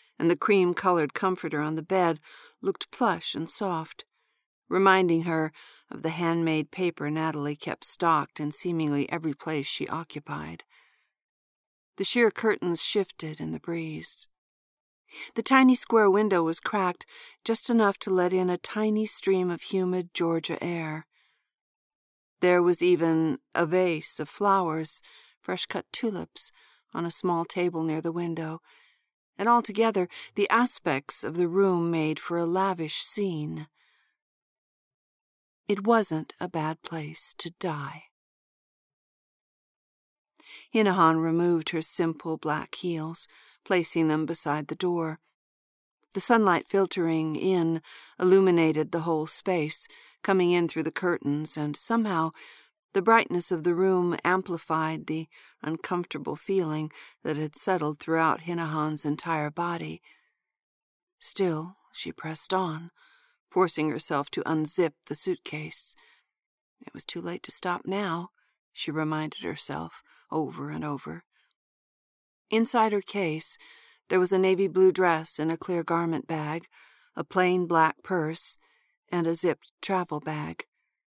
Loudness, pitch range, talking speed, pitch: -27 LUFS, 160-190 Hz, 130 wpm, 170 Hz